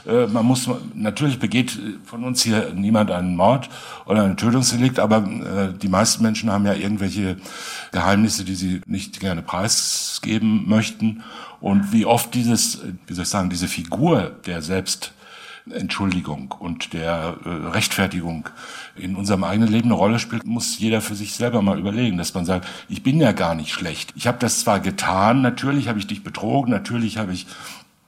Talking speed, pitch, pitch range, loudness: 165 wpm, 105 Hz, 95-115 Hz, -21 LUFS